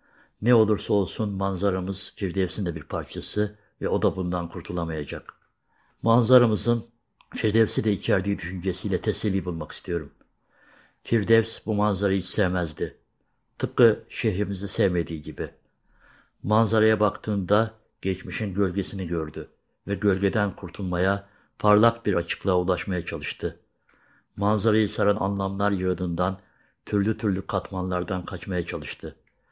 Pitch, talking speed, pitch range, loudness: 100 Hz, 105 wpm, 90-105 Hz, -25 LUFS